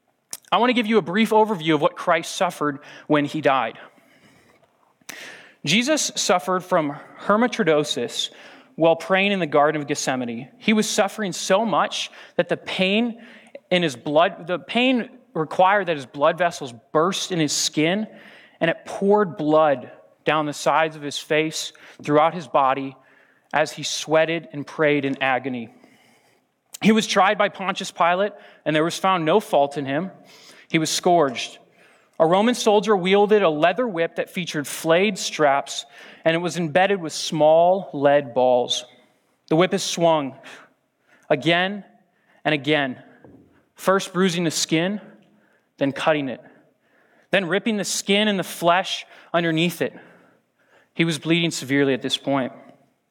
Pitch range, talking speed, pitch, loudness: 150-195 Hz, 150 wpm, 170 Hz, -21 LUFS